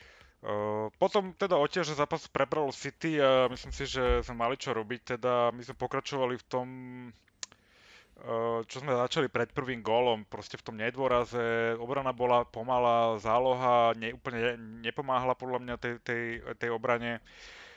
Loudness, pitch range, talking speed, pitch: -31 LUFS, 115-130 Hz, 160 wpm, 125 Hz